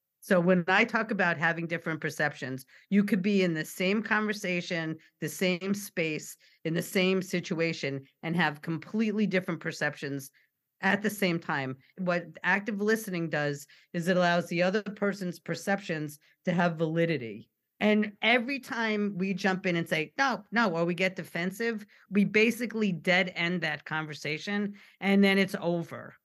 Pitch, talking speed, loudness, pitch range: 180 Hz, 160 wpm, -29 LUFS, 160-200 Hz